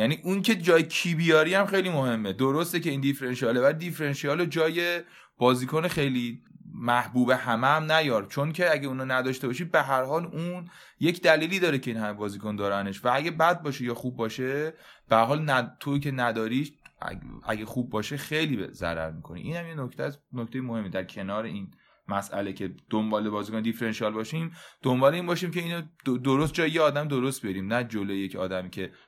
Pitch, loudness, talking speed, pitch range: 135 Hz, -27 LUFS, 195 wpm, 115-160 Hz